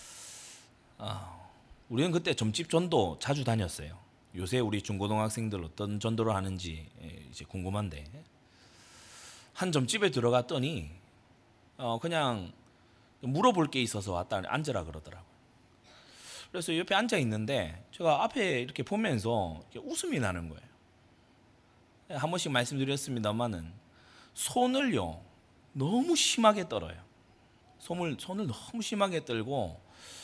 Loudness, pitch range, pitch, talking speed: -32 LUFS, 95-145 Hz, 120 Hz, 270 characters per minute